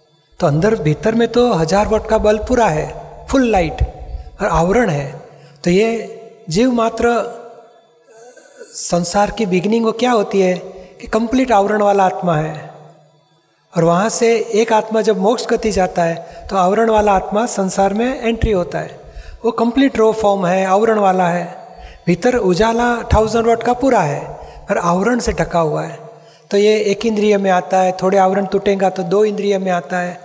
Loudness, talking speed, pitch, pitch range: -15 LUFS, 175 wpm, 210 Hz, 185-230 Hz